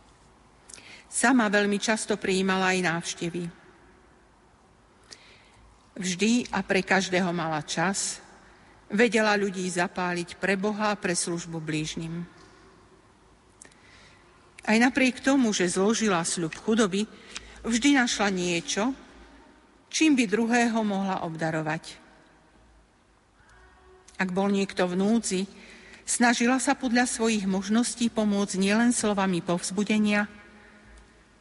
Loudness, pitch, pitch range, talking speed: -25 LUFS, 200 Hz, 185-225 Hz, 95 wpm